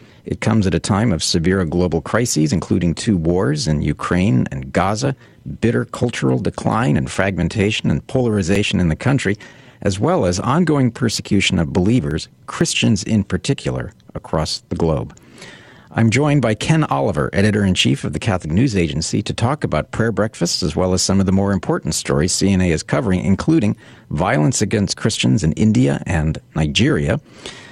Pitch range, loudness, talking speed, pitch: 85-110 Hz, -18 LUFS, 165 wpm, 95 Hz